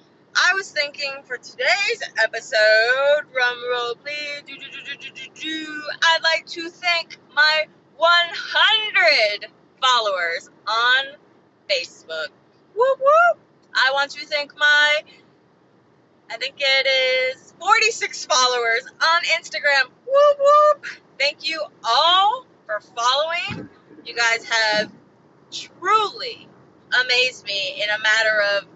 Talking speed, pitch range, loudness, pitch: 120 wpm, 250-335 Hz, -18 LUFS, 290 Hz